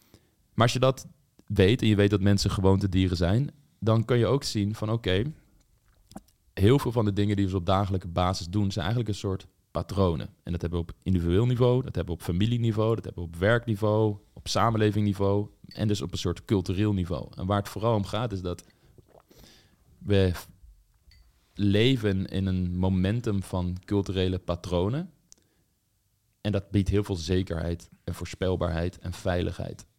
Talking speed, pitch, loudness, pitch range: 180 wpm, 100 Hz, -27 LUFS, 90-110 Hz